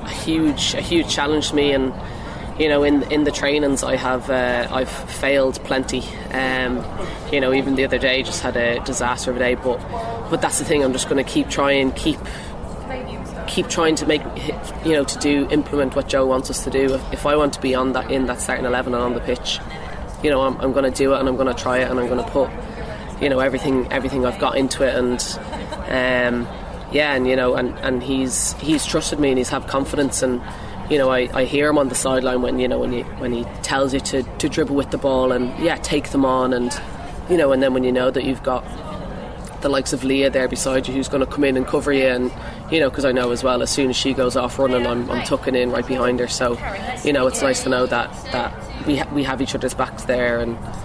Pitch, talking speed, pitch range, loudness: 130 Hz, 255 wpm, 125-135 Hz, -20 LUFS